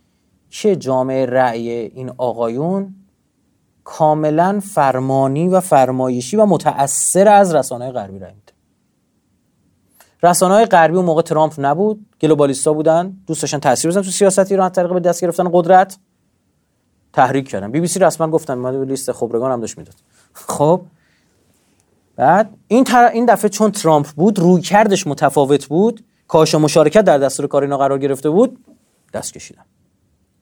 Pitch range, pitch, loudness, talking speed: 130-190 Hz, 155 Hz, -15 LUFS, 145 wpm